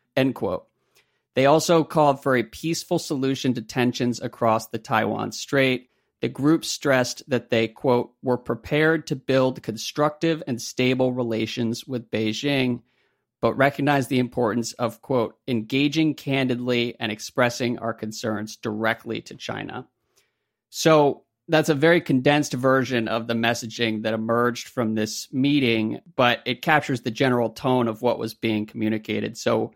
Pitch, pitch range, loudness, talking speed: 125 Hz, 115-140 Hz, -23 LUFS, 145 wpm